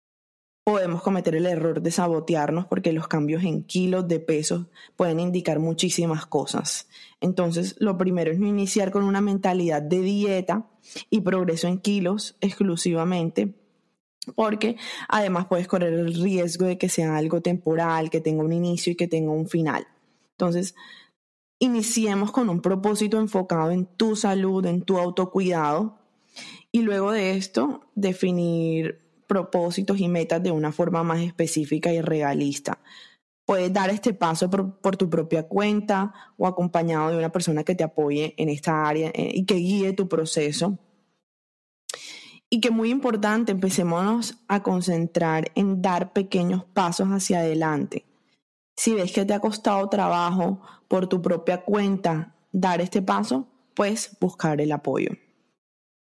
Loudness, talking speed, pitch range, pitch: -24 LUFS, 145 wpm, 165-200 Hz, 180 Hz